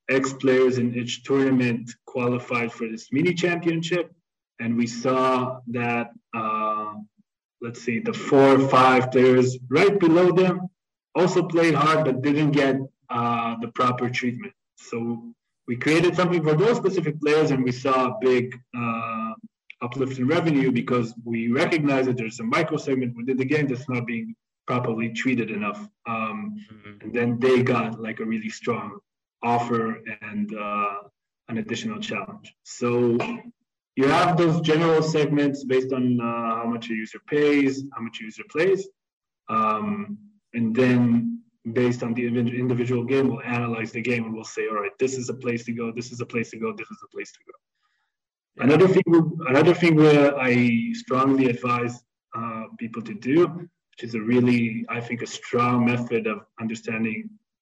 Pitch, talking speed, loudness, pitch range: 125 Hz, 170 wpm, -23 LUFS, 115-155 Hz